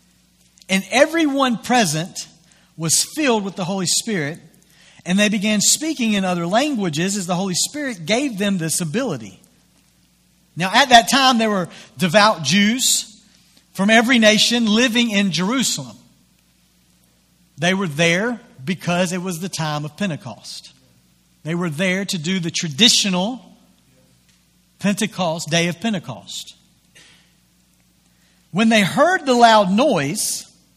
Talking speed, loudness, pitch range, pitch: 125 wpm, -17 LUFS, 165-225 Hz, 190 Hz